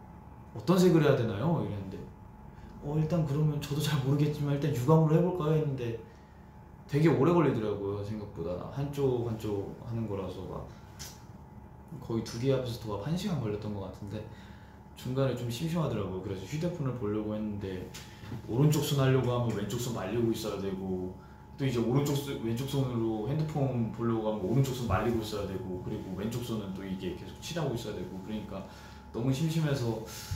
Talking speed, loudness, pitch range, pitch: 370 characters per minute, -31 LUFS, 105-140 Hz, 115 Hz